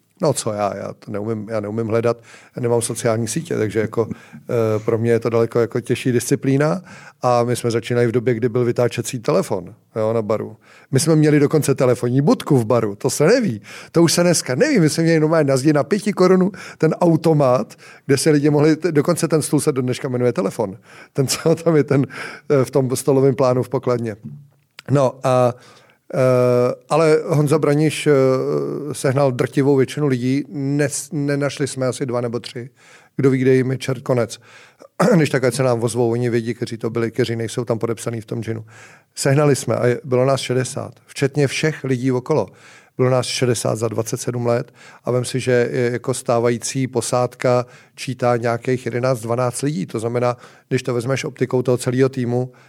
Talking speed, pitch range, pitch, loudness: 190 wpm, 120-145 Hz, 130 Hz, -19 LUFS